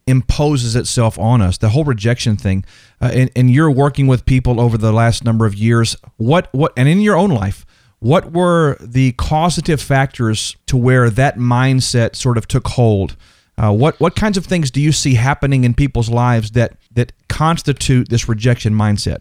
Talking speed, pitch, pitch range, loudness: 185 wpm, 125 Hz, 115-140 Hz, -14 LUFS